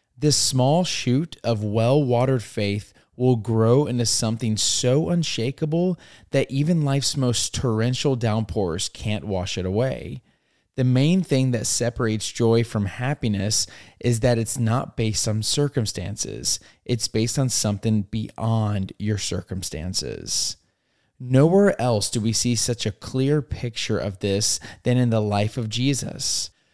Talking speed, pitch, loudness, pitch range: 140 wpm, 115 Hz, -22 LUFS, 105-130 Hz